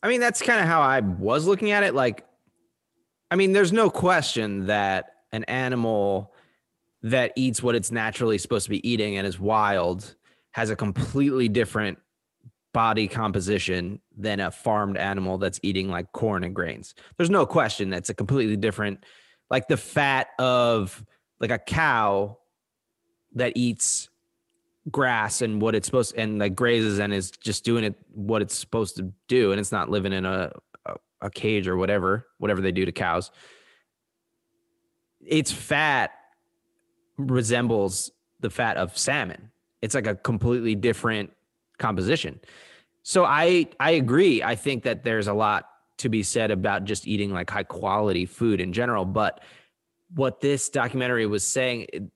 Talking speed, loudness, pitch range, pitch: 160 wpm, -24 LUFS, 100-130 Hz, 110 Hz